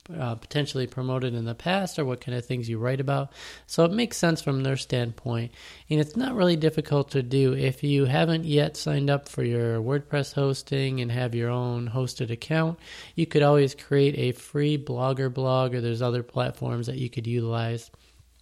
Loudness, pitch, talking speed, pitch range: -26 LUFS, 135 Hz, 195 wpm, 125-145 Hz